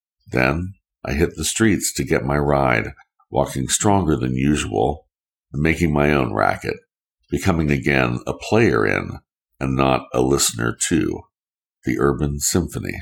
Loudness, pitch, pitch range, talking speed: -20 LUFS, 70 Hz, 65-80 Hz, 145 wpm